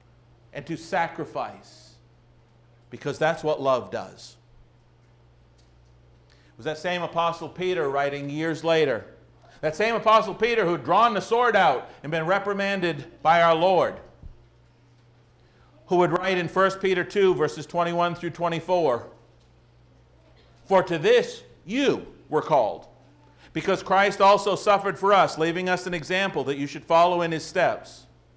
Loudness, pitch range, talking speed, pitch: -23 LUFS, 120-185 Hz, 140 wpm, 165 Hz